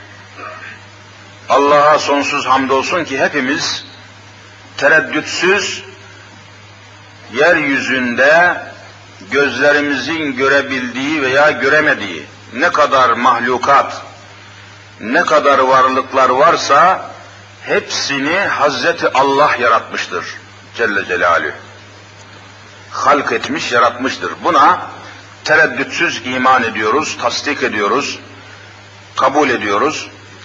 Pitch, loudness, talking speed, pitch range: 105 Hz, -13 LUFS, 70 wpm, 100-135 Hz